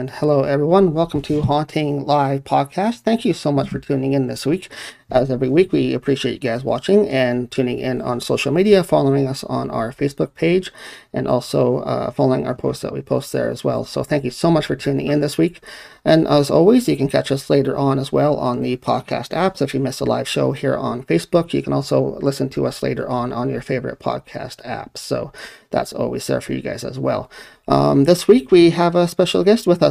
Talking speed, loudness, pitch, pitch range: 230 wpm, -18 LUFS, 140 Hz, 130-170 Hz